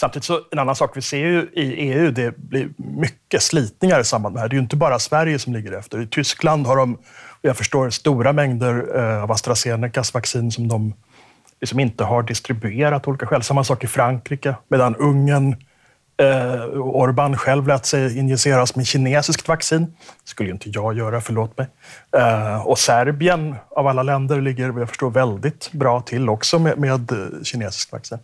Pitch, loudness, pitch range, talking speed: 130 Hz, -19 LUFS, 120-145 Hz, 185 wpm